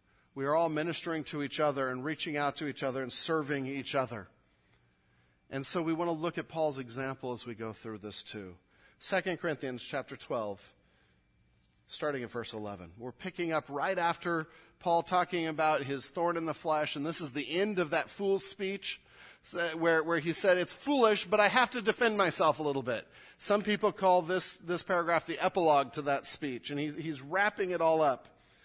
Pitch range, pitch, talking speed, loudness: 135-175 Hz, 155 Hz, 195 wpm, -32 LUFS